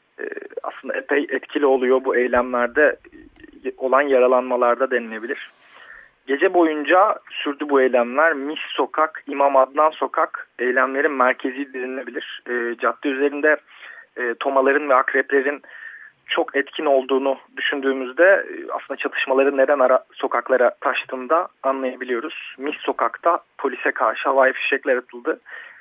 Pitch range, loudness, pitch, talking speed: 130-155 Hz, -20 LUFS, 135 Hz, 105 wpm